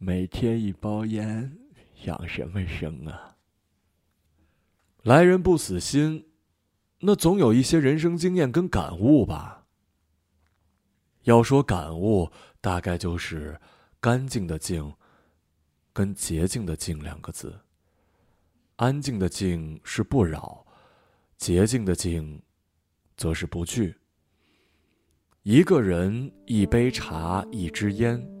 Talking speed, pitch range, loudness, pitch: 150 characters per minute, 80-110 Hz, -24 LUFS, 90 Hz